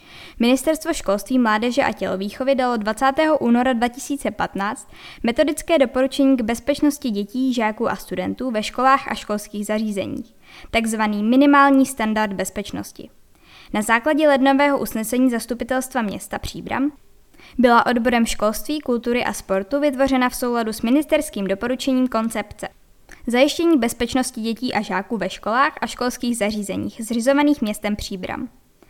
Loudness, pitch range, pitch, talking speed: -20 LUFS, 215-275 Hz, 245 Hz, 125 wpm